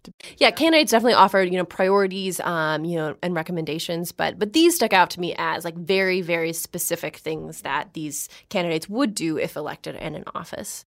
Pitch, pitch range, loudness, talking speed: 180 Hz, 165-195 Hz, -22 LUFS, 200 wpm